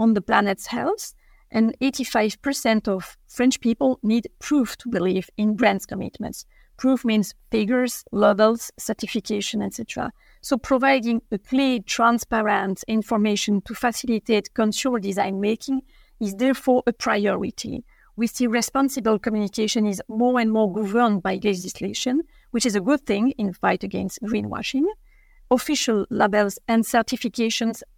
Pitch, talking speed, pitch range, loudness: 230 Hz, 130 wpm, 210-255 Hz, -23 LUFS